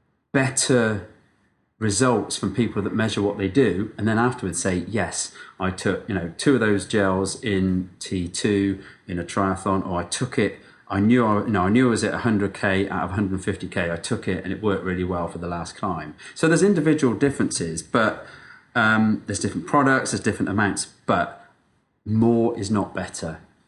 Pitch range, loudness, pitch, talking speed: 95-115 Hz, -23 LUFS, 100 Hz, 205 wpm